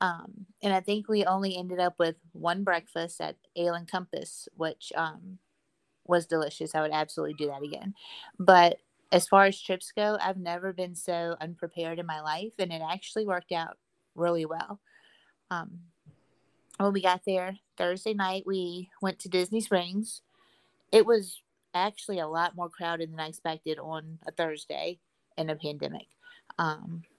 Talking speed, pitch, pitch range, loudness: 170 wpm, 180 Hz, 165-195 Hz, -30 LUFS